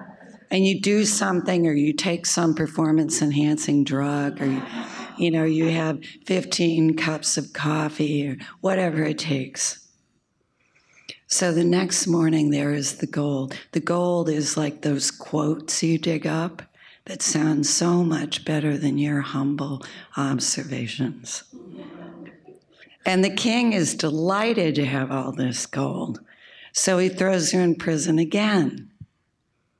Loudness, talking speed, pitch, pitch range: -23 LUFS, 135 wpm, 155 Hz, 145-175 Hz